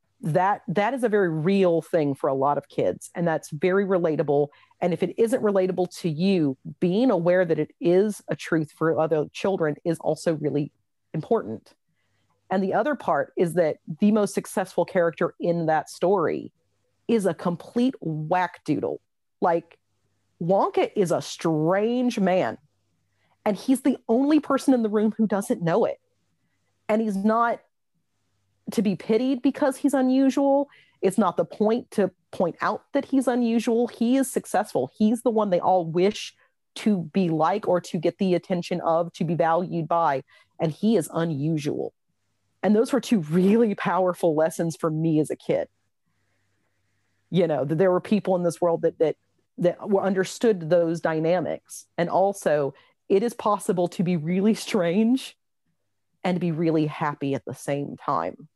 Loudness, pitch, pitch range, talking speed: -24 LUFS, 180 Hz, 165-215 Hz, 170 wpm